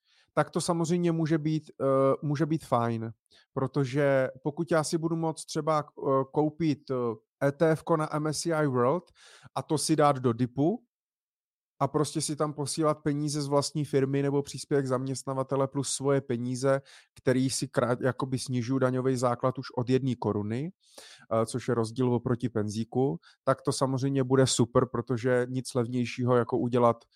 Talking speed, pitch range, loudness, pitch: 145 wpm, 125-150 Hz, -28 LUFS, 135 Hz